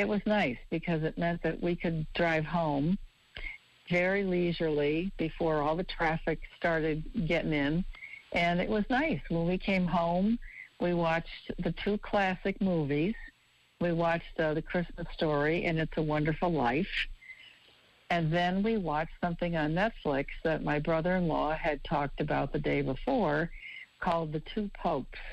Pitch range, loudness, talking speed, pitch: 155-185 Hz, -31 LUFS, 160 wpm, 170 Hz